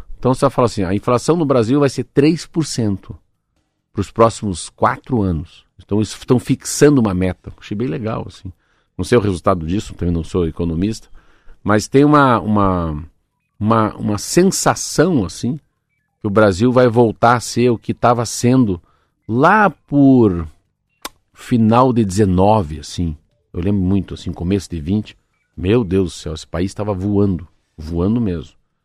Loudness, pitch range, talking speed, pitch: -16 LUFS, 95-120 Hz, 160 wpm, 105 Hz